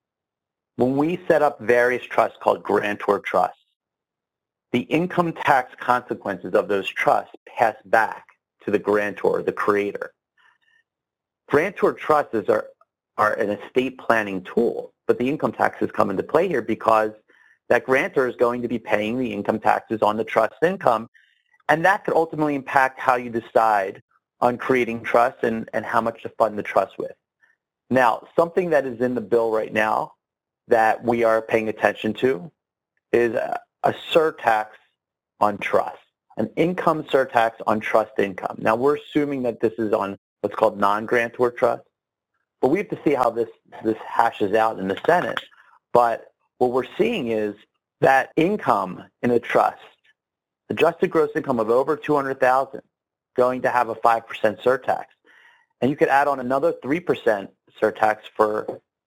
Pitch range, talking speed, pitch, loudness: 110-155 Hz, 155 wpm, 125 Hz, -22 LUFS